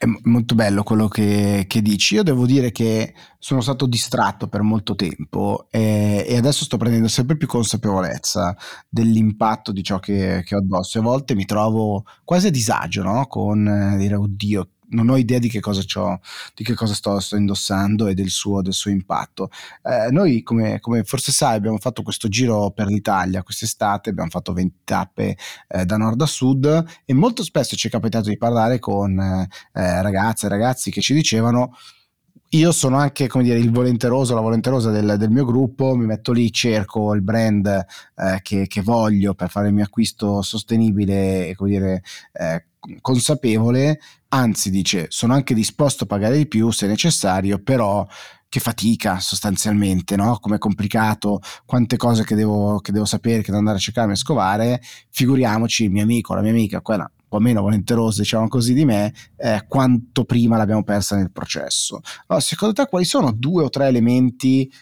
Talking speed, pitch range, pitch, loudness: 185 wpm, 100-125 Hz, 110 Hz, -19 LUFS